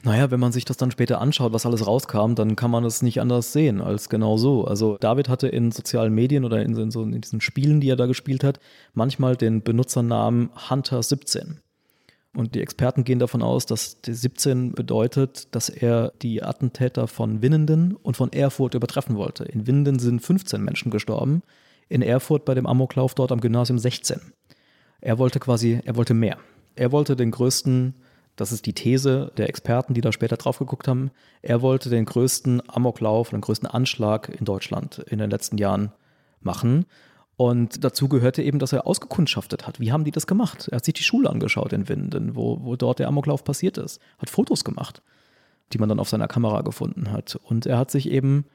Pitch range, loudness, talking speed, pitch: 115-140 Hz, -23 LUFS, 200 wpm, 125 Hz